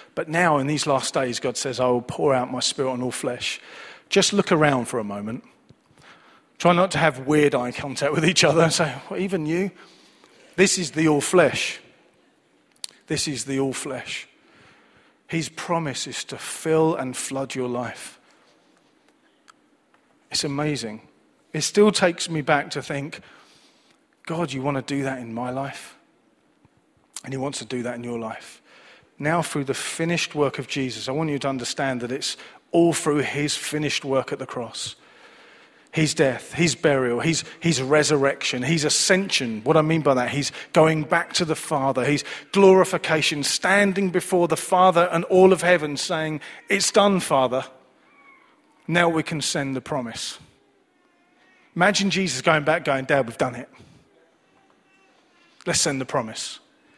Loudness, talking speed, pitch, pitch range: -22 LUFS, 165 wpm, 155 Hz, 135-175 Hz